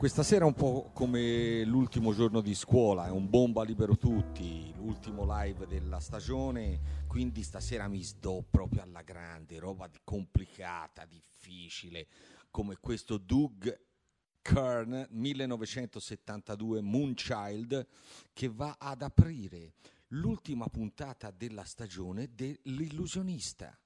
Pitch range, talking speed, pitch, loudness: 90-125 Hz, 110 wpm, 110 Hz, -34 LUFS